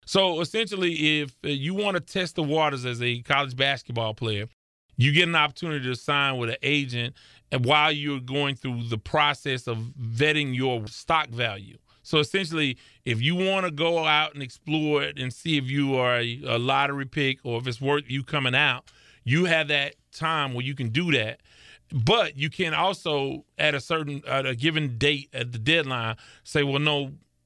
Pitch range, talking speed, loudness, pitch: 125-155 Hz, 190 wpm, -25 LUFS, 140 Hz